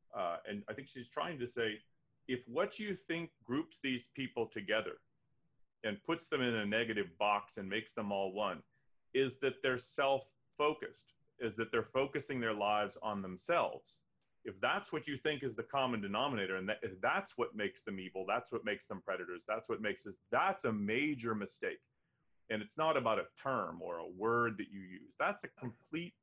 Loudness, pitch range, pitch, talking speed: -38 LUFS, 110-150 Hz, 125 Hz, 195 wpm